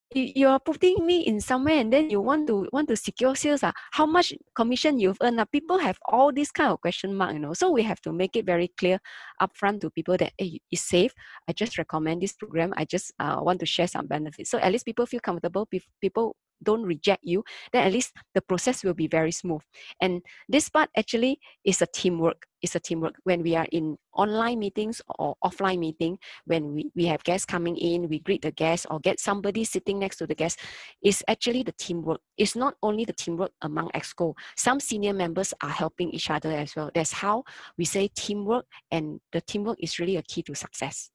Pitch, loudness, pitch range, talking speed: 190 Hz, -26 LUFS, 165-225 Hz, 220 wpm